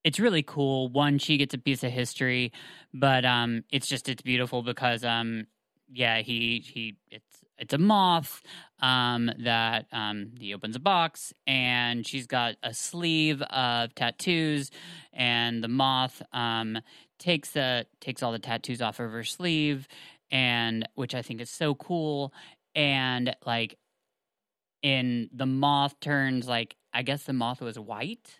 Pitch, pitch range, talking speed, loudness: 125 Hz, 120-140 Hz, 155 wpm, -28 LUFS